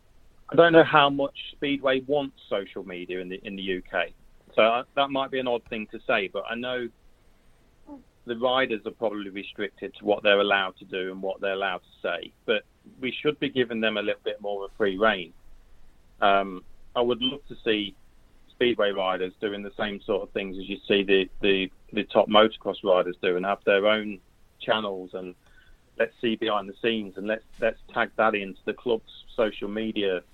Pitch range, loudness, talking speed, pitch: 95-125 Hz, -26 LUFS, 200 wpm, 105 Hz